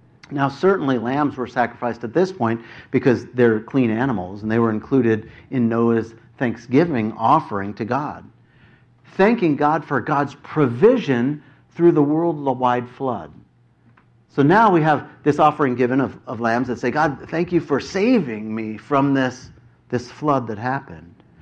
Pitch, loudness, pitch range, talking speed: 125 Hz, -20 LUFS, 115-145 Hz, 155 wpm